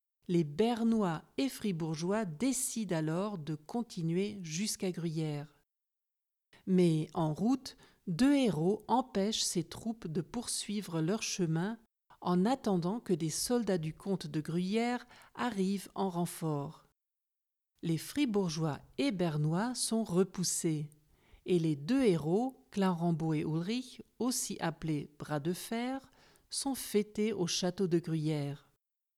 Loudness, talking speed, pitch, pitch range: -34 LUFS, 120 wpm, 185 Hz, 160-220 Hz